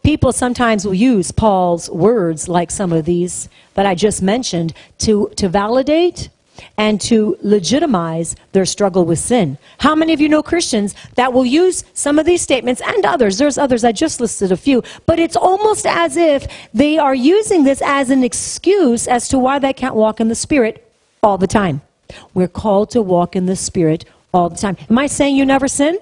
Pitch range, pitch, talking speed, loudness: 195-280 Hz, 230 Hz, 200 wpm, -15 LUFS